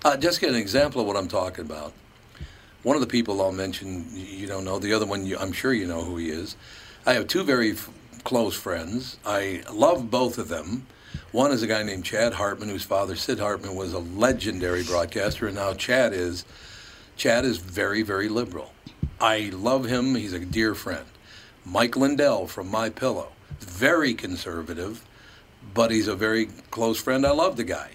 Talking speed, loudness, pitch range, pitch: 195 wpm, -25 LUFS, 95-120 Hz, 105 Hz